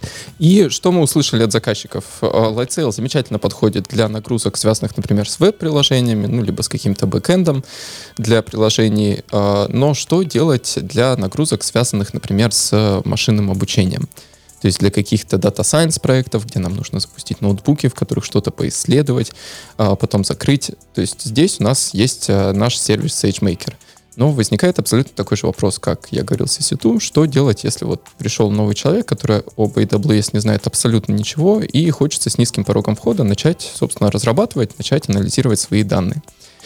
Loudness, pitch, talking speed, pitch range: -16 LUFS, 115 Hz, 155 wpm, 105-140 Hz